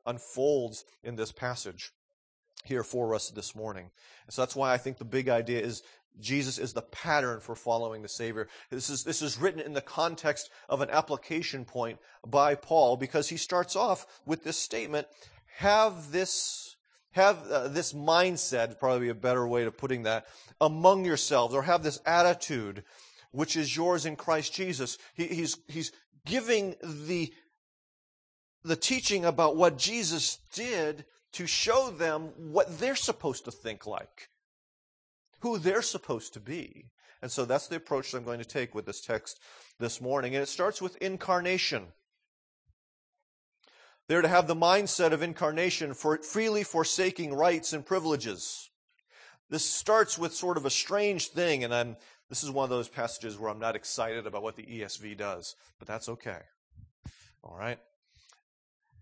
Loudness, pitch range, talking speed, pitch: -30 LUFS, 120-175 Hz, 165 wpm, 150 Hz